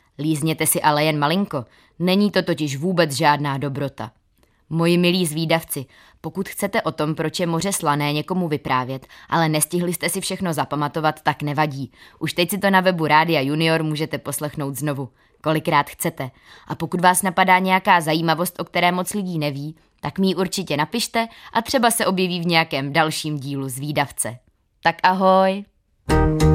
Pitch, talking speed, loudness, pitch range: 160 Hz, 165 wpm, -20 LUFS, 145-180 Hz